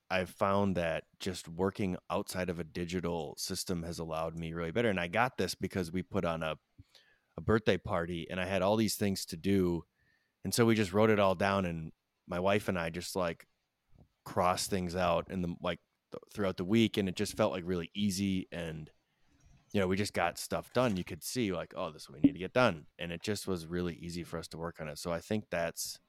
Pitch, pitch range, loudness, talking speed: 90 Hz, 85-100 Hz, -34 LUFS, 235 wpm